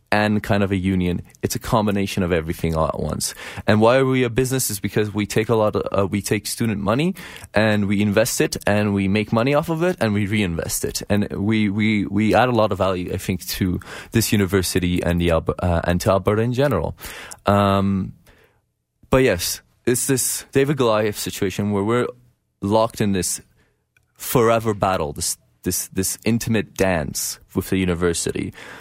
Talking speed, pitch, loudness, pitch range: 190 wpm, 105 Hz, -20 LUFS, 95-110 Hz